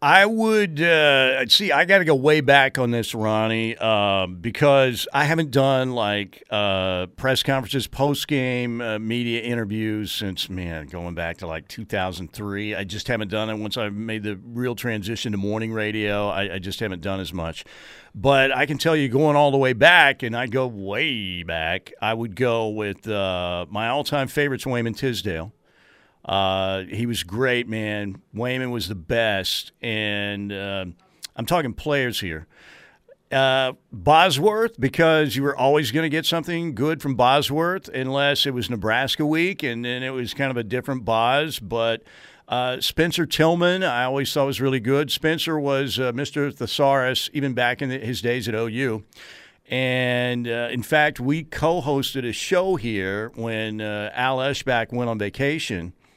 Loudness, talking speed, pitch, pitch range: -22 LUFS, 175 wpm, 120 Hz, 105-140 Hz